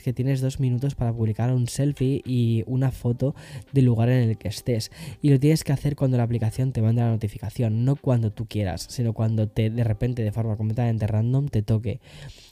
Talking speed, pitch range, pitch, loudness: 210 wpm, 110-130 Hz, 120 Hz, -24 LUFS